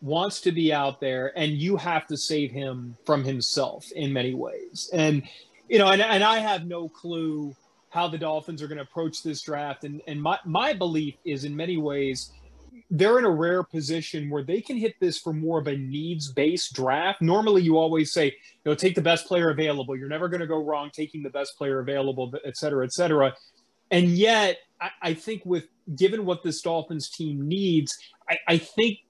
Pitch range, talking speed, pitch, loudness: 145-175 Hz, 205 wpm, 160 Hz, -25 LUFS